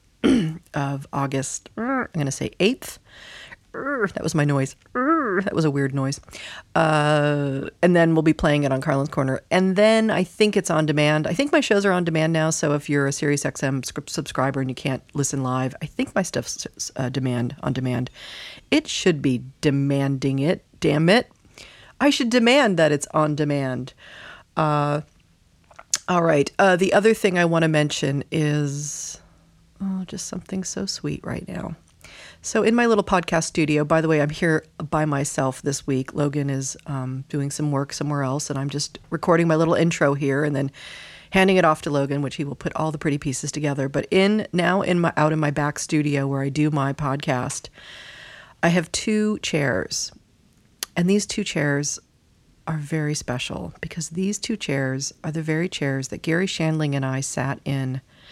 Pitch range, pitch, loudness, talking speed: 140-175 Hz, 150 Hz, -22 LUFS, 185 wpm